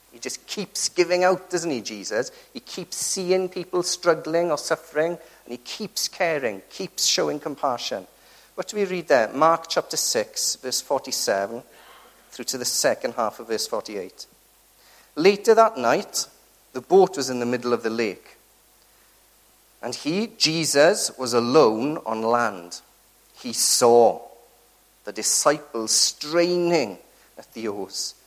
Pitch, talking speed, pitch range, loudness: 160 Hz, 140 wpm, 120-180 Hz, -22 LUFS